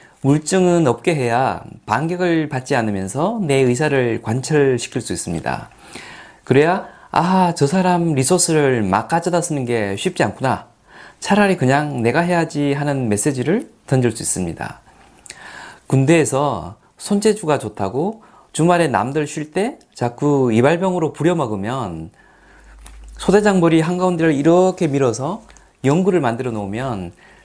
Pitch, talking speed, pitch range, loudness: 145 Hz, 285 characters per minute, 120-175 Hz, -18 LUFS